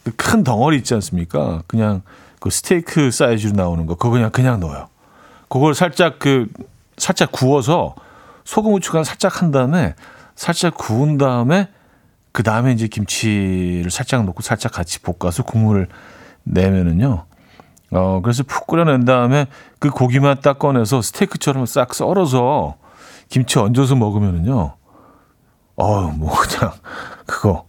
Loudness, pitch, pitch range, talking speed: -17 LUFS, 125 Hz, 100-145 Hz, 295 characters per minute